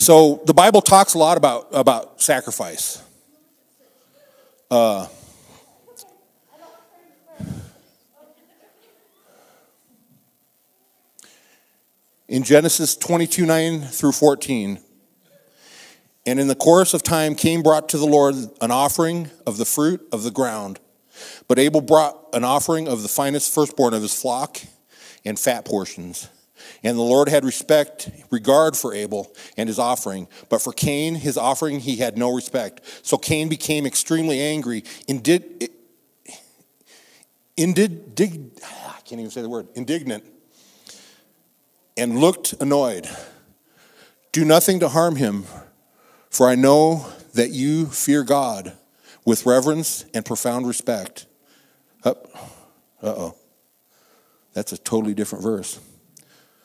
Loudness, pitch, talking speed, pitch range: -19 LUFS, 150 Hz, 120 wpm, 125-165 Hz